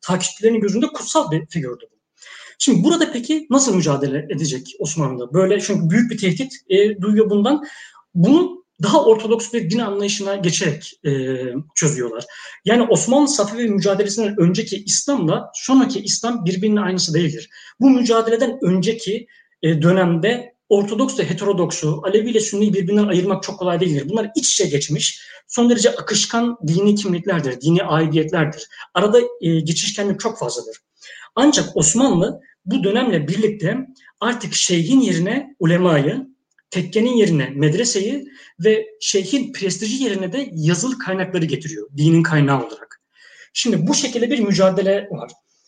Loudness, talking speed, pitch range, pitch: -18 LUFS, 135 wpm, 170-240 Hz, 200 Hz